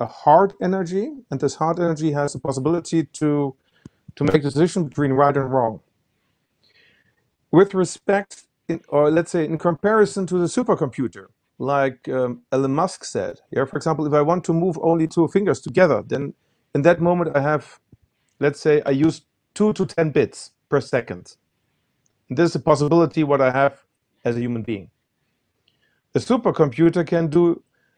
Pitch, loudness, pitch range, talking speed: 155 Hz, -20 LUFS, 140-175 Hz, 170 wpm